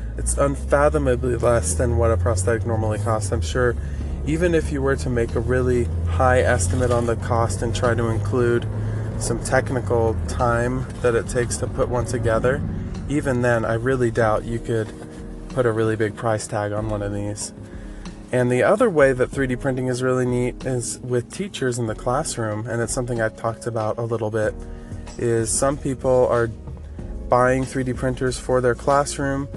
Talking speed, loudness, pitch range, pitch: 185 wpm, -22 LUFS, 105-125 Hz, 115 Hz